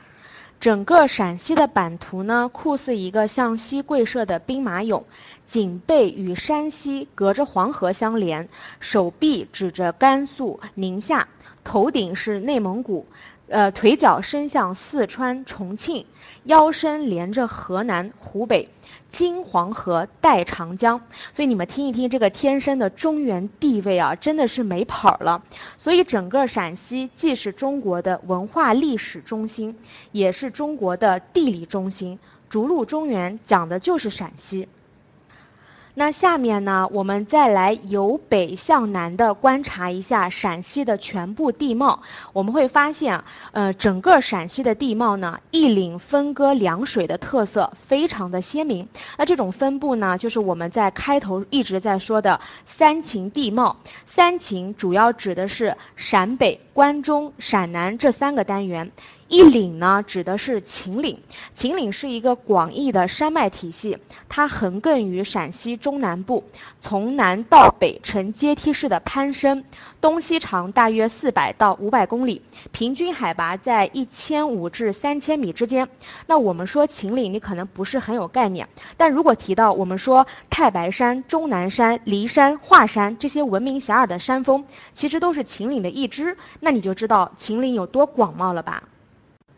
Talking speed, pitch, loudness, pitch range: 235 characters per minute, 230 Hz, -20 LUFS, 195-280 Hz